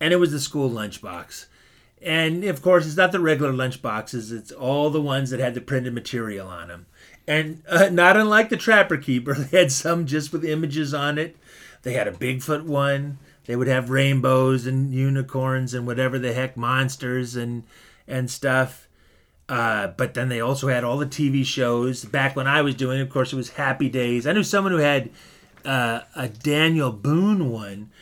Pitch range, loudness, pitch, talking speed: 125-155 Hz, -22 LUFS, 135 Hz, 195 wpm